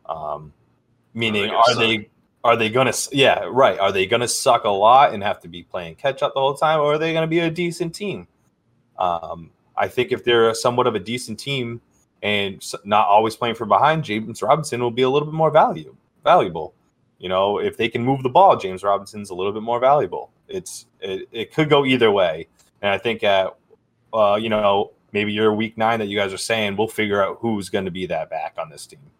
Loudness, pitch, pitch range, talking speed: -19 LUFS, 115 Hz, 105-150 Hz, 220 wpm